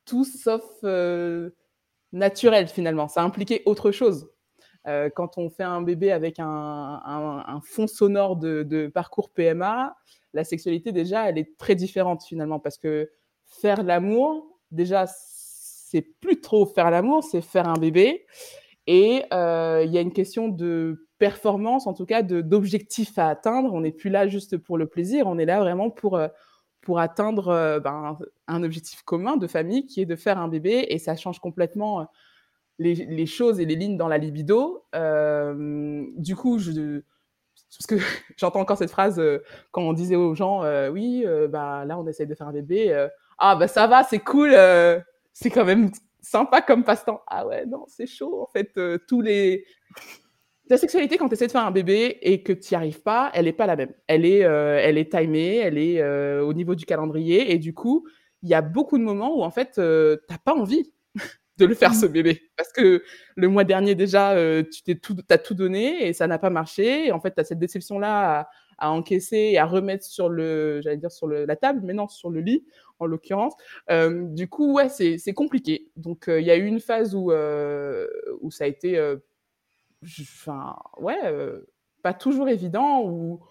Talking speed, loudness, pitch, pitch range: 200 wpm, -22 LUFS, 185 Hz, 160-225 Hz